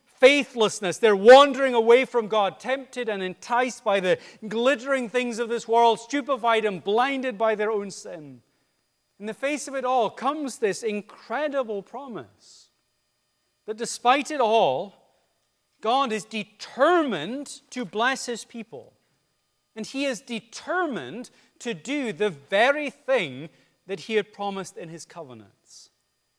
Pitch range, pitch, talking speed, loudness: 200-255 Hz, 230 Hz, 135 wpm, -23 LUFS